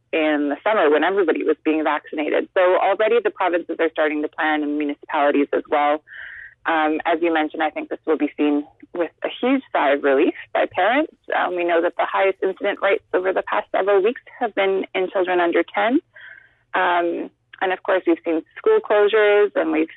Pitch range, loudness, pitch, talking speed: 155-205 Hz, -20 LUFS, 175 Hz, 200 wpm